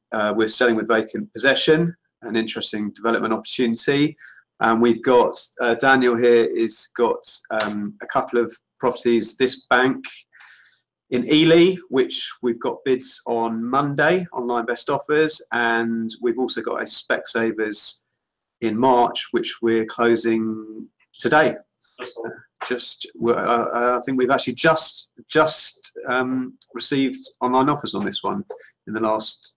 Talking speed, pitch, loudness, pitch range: 140 wpm, 120 Hz, -20 LUFS, 115-135 Hz